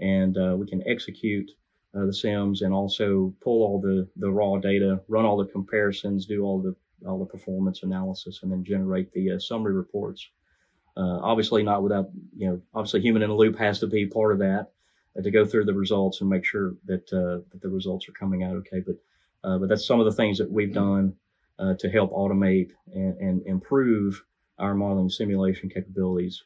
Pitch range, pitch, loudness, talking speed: 95-105 Hz, 95 Hz, -25 LUFS, 205 wpm